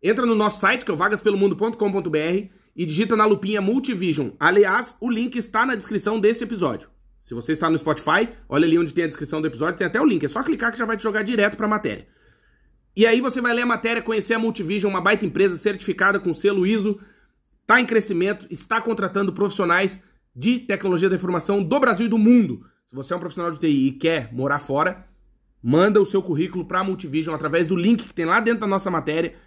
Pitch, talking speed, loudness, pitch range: 200 Hz, 225 wpm, -21 LUFS, 170-220 Hz